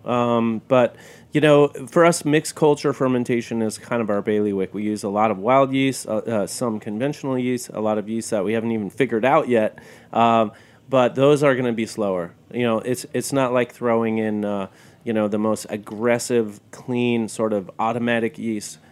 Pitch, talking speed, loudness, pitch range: 115 Hz, 205 wpm, -21 LUFS, 110-125 Hz